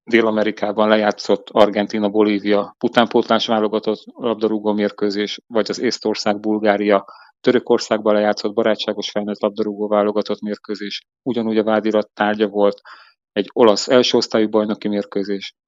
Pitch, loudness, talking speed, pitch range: 105 Hz, -18 LUFS, 105 wpm, 105-110 Hz